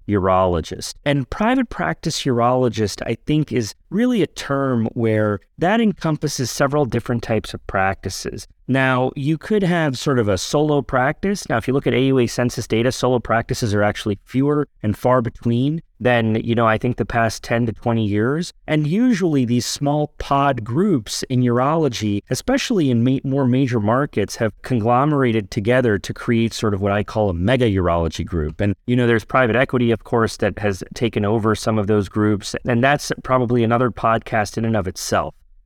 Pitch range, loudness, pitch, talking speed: 110-140 Hz, -19 LUFS, 120 Hz, 180 wpm